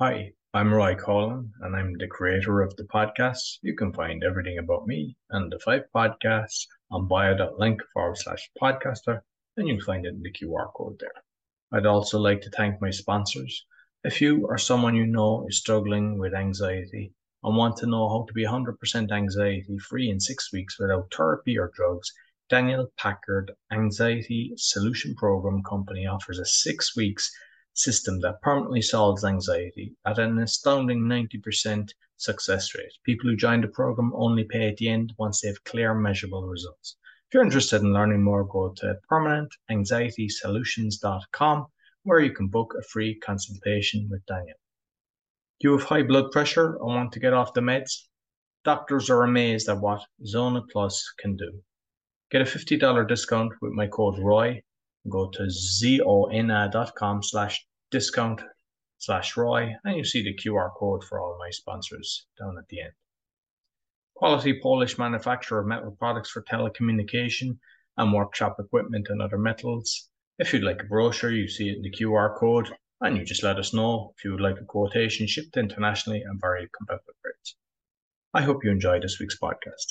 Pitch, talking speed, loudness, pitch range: 110 Hz, 170 wpm, -26 LUFS, 100-120 Hz